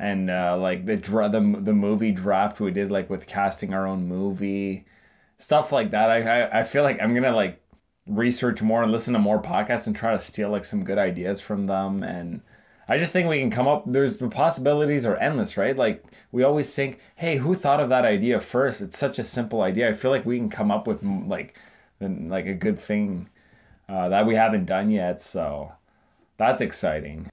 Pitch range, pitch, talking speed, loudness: 100-135 Hz, 110 Hz, 215 wpm, -24 LUFS